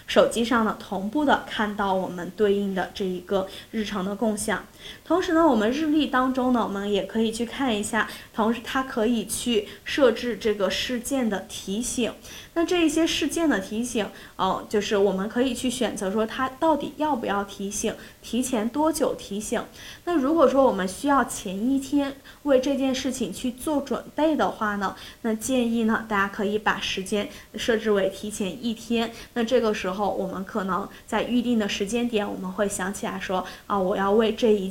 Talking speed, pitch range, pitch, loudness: 280 characters per minute, 205-255 Hz, 225 Hz, -25 LUFS